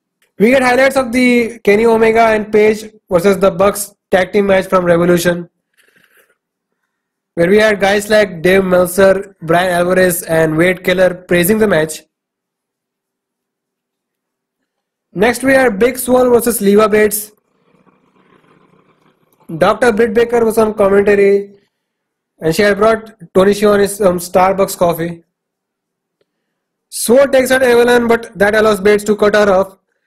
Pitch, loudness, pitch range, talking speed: 205 Hz, -12 LUFS, 185-225 Hz, 135 wpm